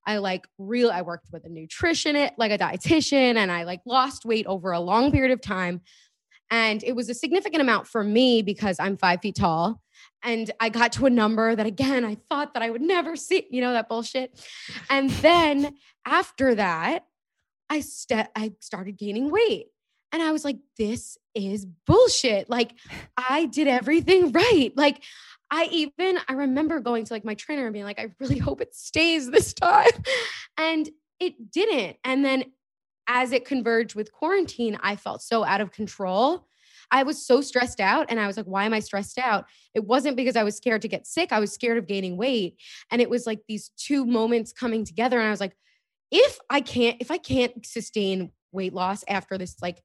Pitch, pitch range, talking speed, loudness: 240 Hz, 215-290 Hz, 200 wpm, -24 LUFS